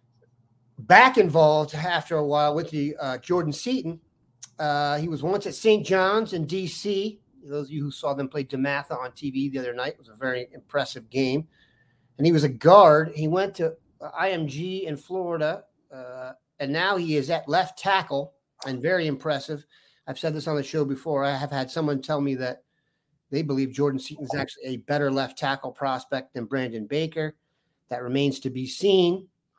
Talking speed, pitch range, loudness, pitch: 190 wpm, 135-165 Hz, -24 LUFS, 145 Hz